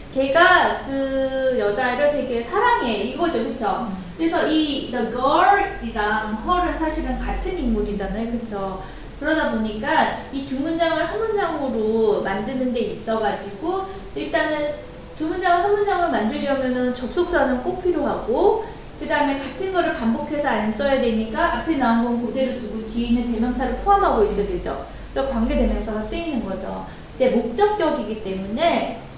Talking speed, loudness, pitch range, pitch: 335 characters per minute, -21 LUFS, 225-325 Hz, 265 Hz